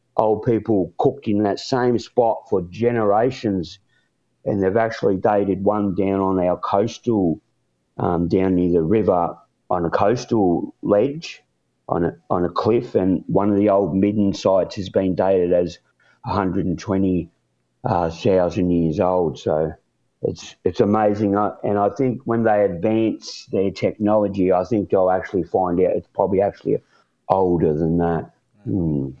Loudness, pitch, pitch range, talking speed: -20 LUFS, 95 Hz, 90-105 Hz, 160 wpm